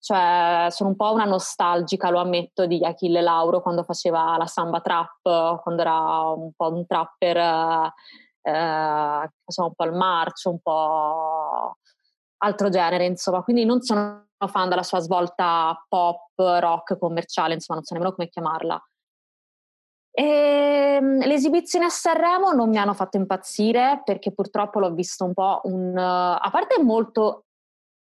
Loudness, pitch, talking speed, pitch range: -22 LUFS, 180 Hz, 145 wpm, 170-200 Hz